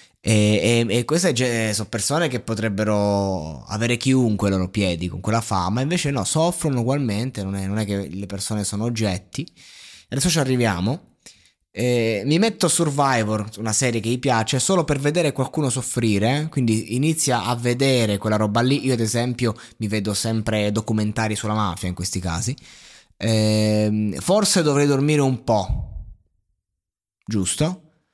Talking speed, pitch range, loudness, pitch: 160 wpm, 105-135 Hz, -21 LUFS, 115 Hz